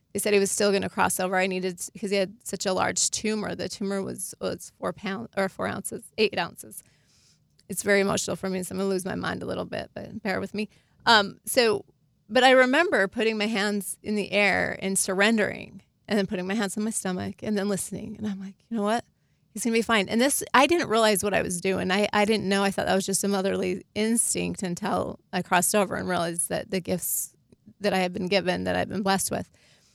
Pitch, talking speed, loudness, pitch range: 195 Hz, 245 wpm, -25 LUFS, 185-210 Hz